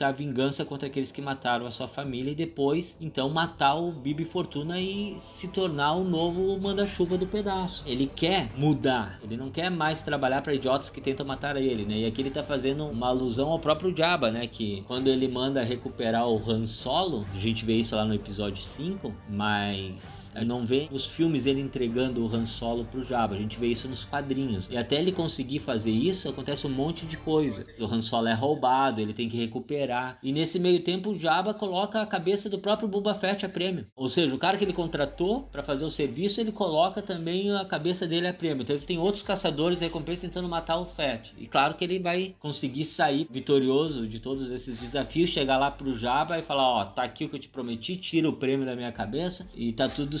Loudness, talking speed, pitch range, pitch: -28 LUFS, 225 wpm, 125-170 Hz, 140 Hz